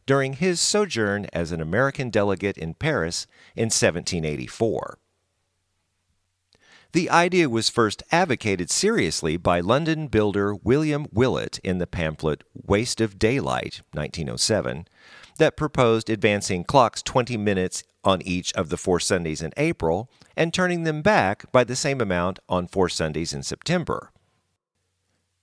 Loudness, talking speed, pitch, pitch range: -23 LUFS, 130 wpm, 100 Hz, 90-125 Hz